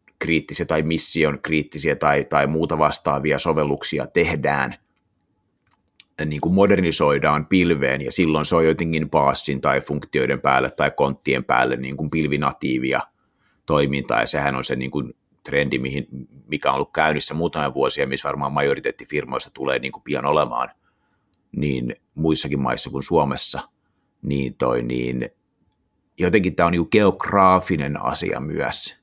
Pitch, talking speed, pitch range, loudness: 75 Hz, 140 wpm, 70-80 Hz, -21 LUFS